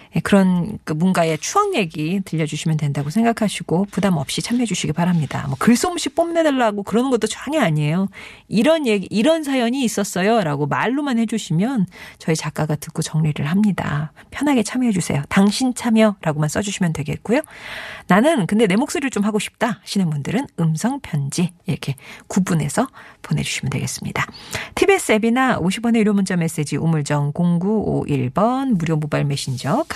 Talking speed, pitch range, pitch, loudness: 365 characters per minute, 160-230 Hz, 200 Hz, -19 LUFS